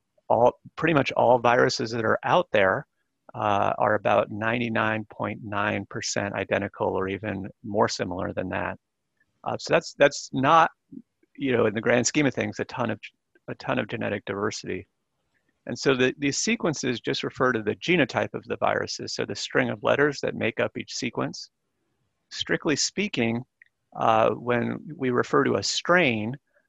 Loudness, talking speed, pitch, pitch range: -25 LUFS, 165 wpm, 115 Hz, 105-130 Hz